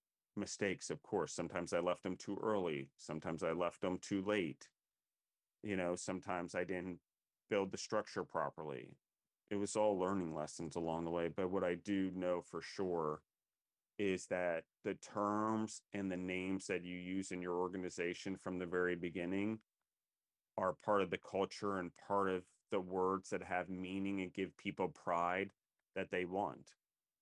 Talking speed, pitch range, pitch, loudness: 170 wpm, 90-100 Hz, 90 Hz, -41 LUFS